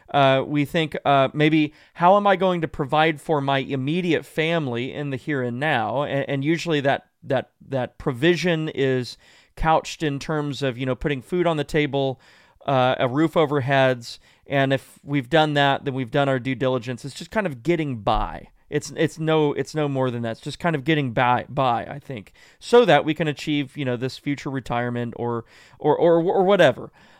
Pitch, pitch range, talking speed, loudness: 145 Hz, 130-155 Hz, 205 wpm, -22 LUFS